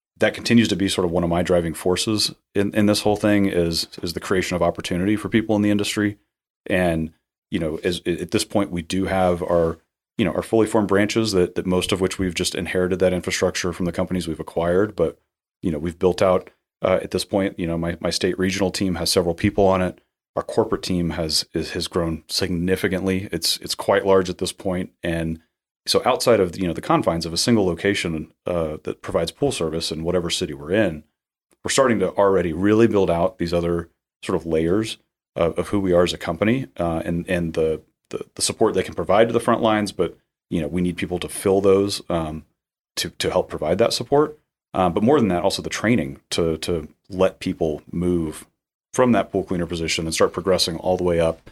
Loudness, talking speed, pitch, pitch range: -21 LUFS, 225 wpm, 90 Hz, 85-100 Hz